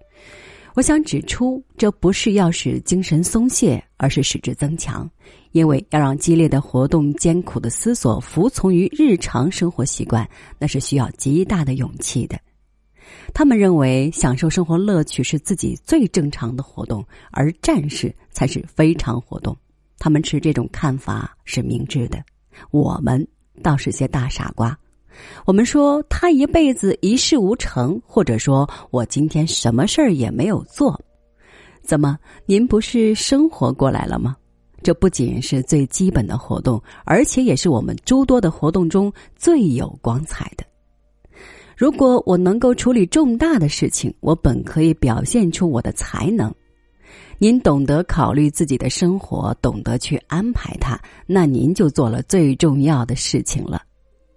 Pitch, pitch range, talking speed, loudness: 155 Hz, 135-195 Hz, 235 characters per minute, -18 LUFS